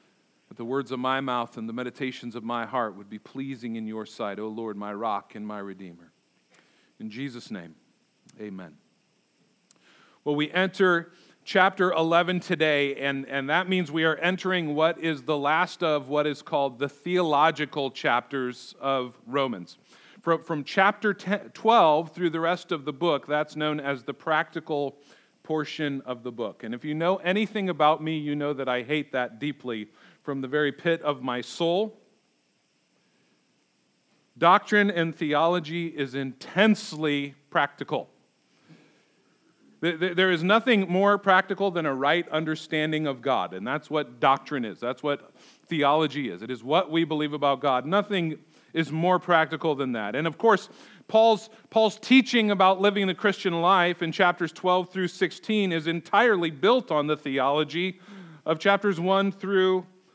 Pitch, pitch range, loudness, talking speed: 155 Hz, 140-185 Hz, -25 LUFS, 160 wpm